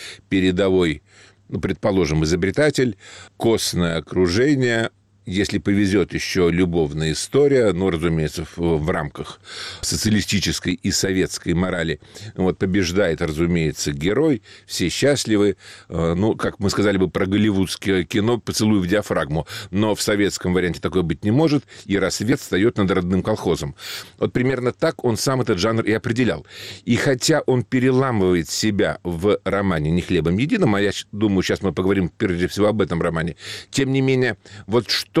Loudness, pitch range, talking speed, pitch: -20 LUFS, 90-110 Hz, 145 wpm, 100 Hz